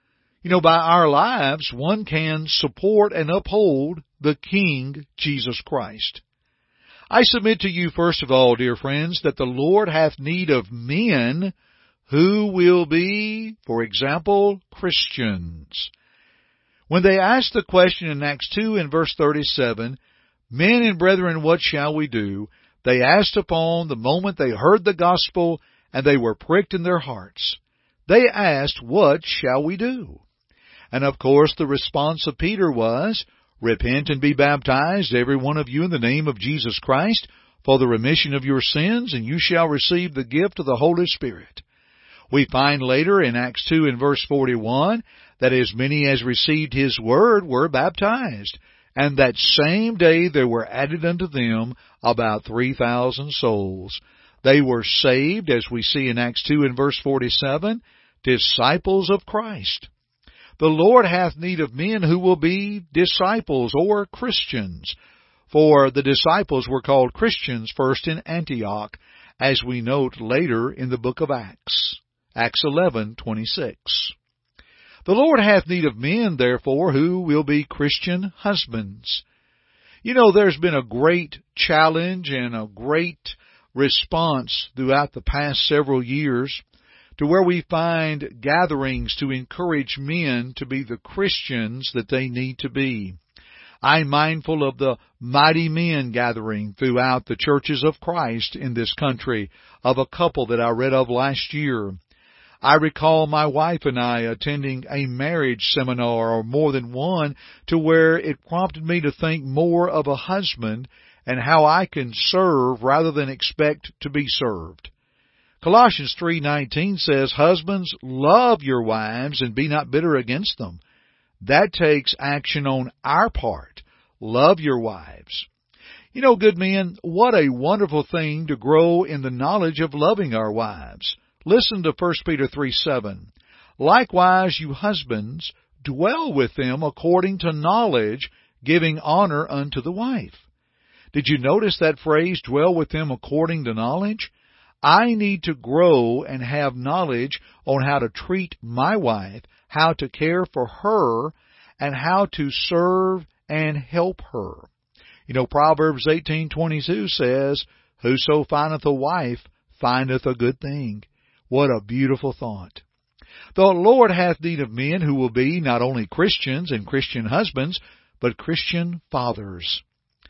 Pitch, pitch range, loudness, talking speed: 145 Hz, 125-170 Hz, -20 LUFS, 150 wpm